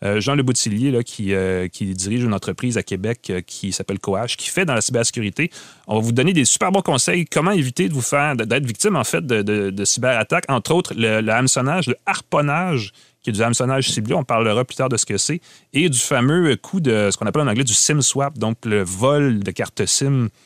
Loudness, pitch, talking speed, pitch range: -19 LUFS, 125 Hz, 230 wpm, 105-145 Hz